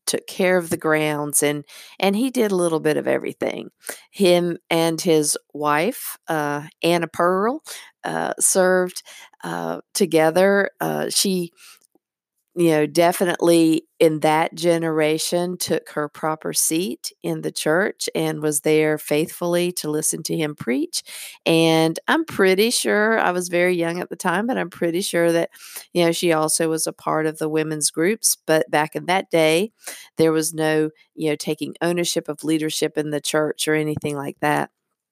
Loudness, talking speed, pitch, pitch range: -20 LUFS, 165 wpm, 165 Hz, 155-180 Hz